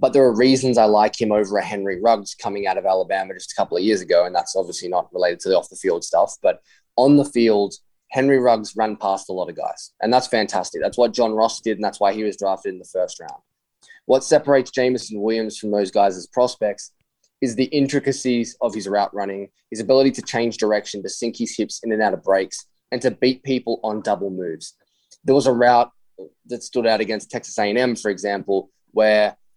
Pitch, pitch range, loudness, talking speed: 110 Hz, 100-125 Hz, -20 LUFS, 220 wpm